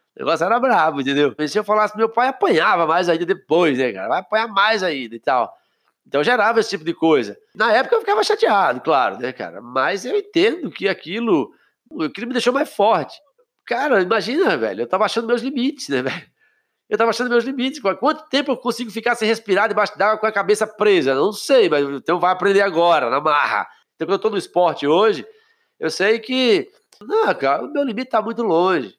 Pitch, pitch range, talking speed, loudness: 225 Hz, 190-285 Hz, 215 wpm, -18 LUFS